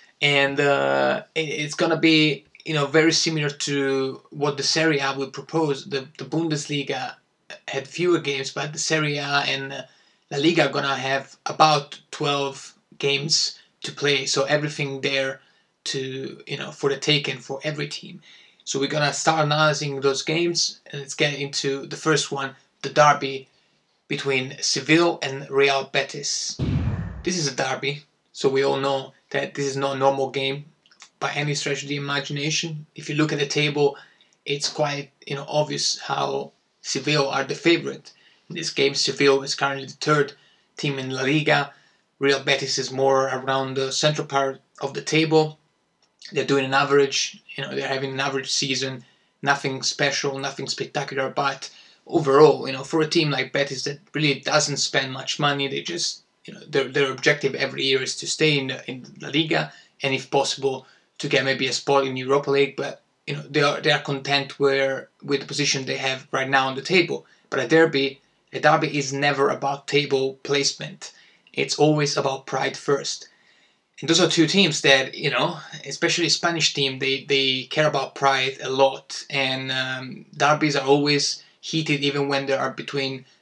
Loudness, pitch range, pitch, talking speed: -22 LUFS, 135-150 Hz, 140 Hz, 185 wpm